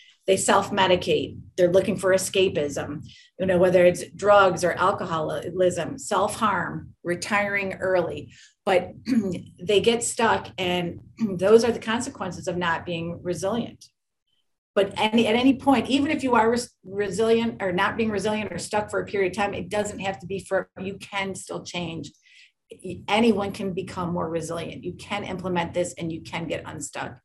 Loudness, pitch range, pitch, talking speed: -24 LUFS, 180-210 Hz, 195 Hz, 165 wpm